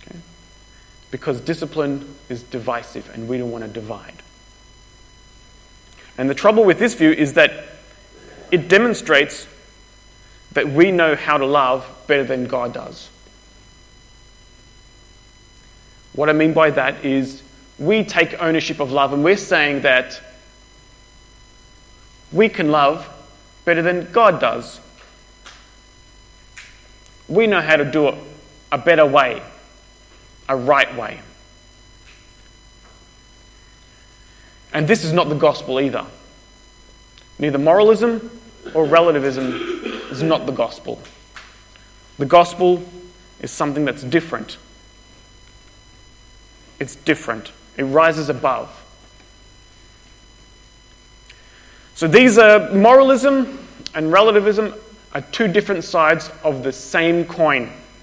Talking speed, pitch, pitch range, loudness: 110 wpm, 130 Hz, 110-160 Hz, -16 LUFS